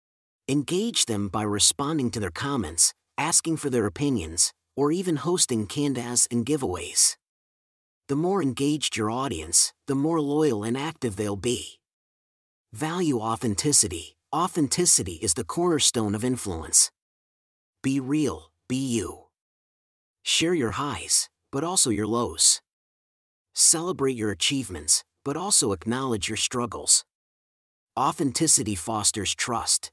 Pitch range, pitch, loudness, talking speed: 105-145 Hz, 125 Hz, -23 LUFS, 120 wpm